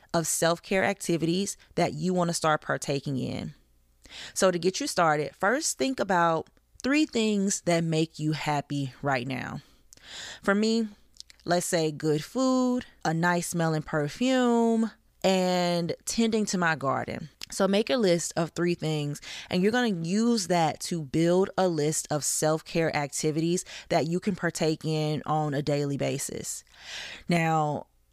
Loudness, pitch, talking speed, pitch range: -27 LUFS, 170 Hz, 155 wpm, 155-195 Hz